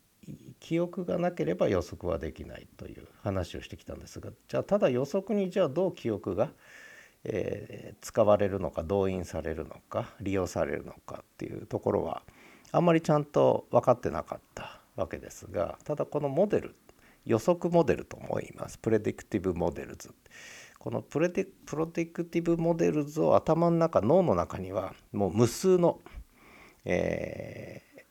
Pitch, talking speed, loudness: 160 Hz, 325 characters per minute, -29 LUFS